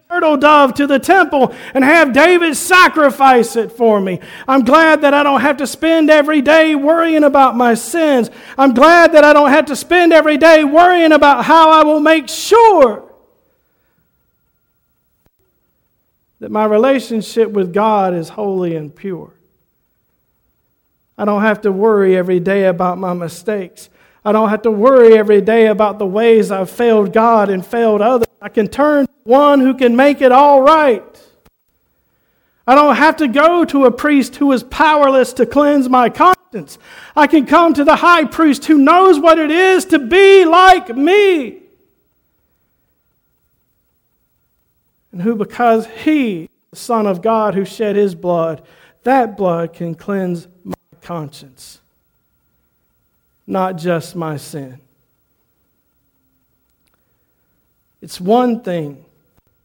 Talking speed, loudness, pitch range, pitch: 145 wpm, -11 LUFS, 205-310 Hz, 250 Hz